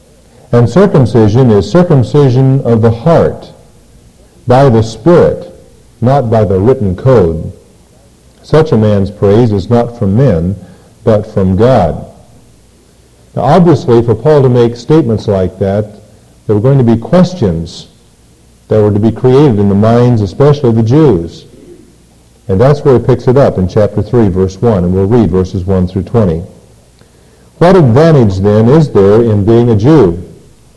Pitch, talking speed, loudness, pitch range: 115 Hz, 160 wpm, -8 LUFS, 100-130 Hz